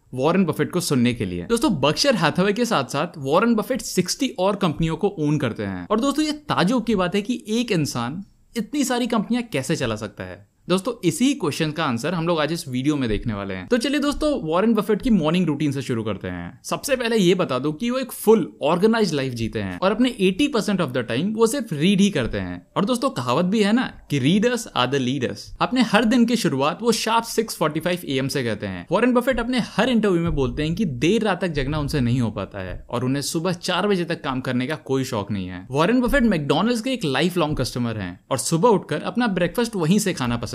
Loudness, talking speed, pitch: -22 LUFS, 240 wpm, 175 Hz